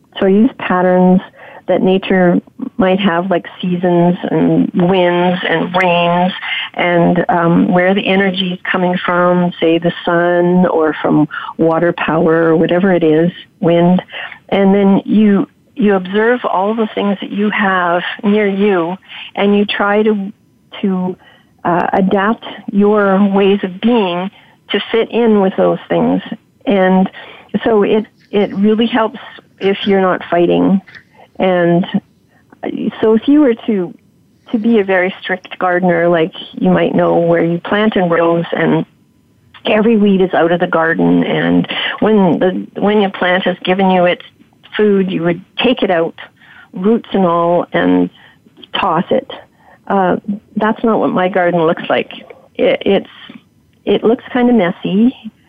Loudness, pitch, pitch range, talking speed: -13 LUFS, 185 Hz, 175-210 Hz, 150 wpm